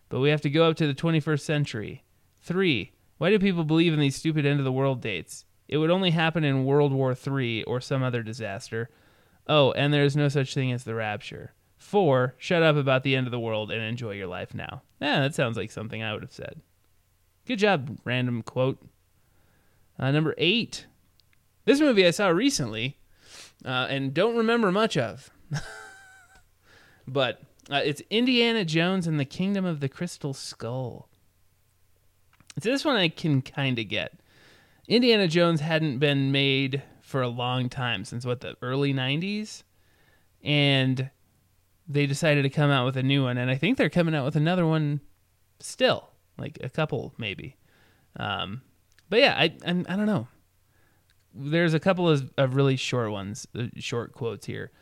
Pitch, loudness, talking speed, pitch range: 135 Hz, -25 LUFS, 180 wpm, 110-155 Hz